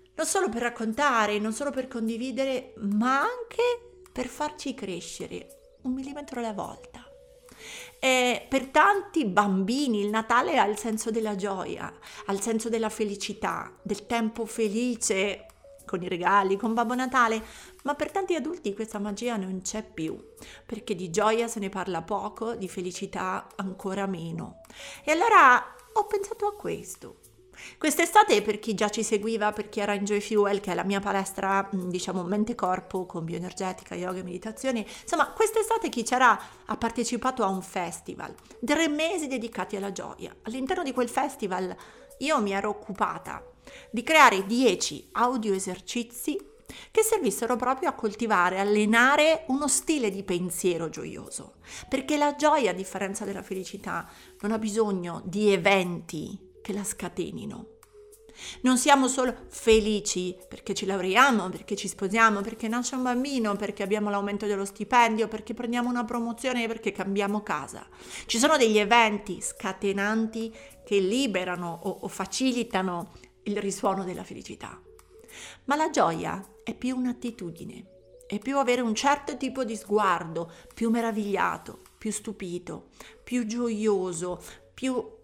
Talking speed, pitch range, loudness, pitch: 145 wpm, 195-255 Hz, -27 LUFS, 220 Hz